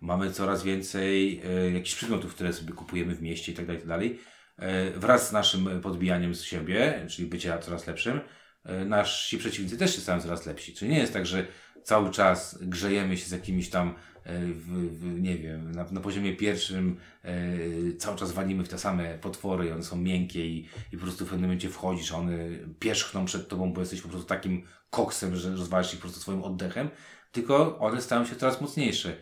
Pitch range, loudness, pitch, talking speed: 85-95 Hz, -30 LUFS, 90 Hz, 200 wpm